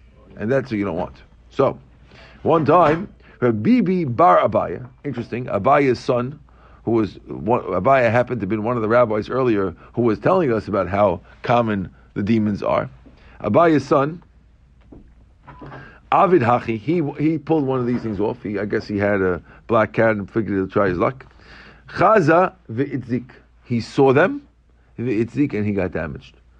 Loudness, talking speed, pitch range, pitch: -19 LUFS, 165 wpm, 100-125 Hz, 115 Hz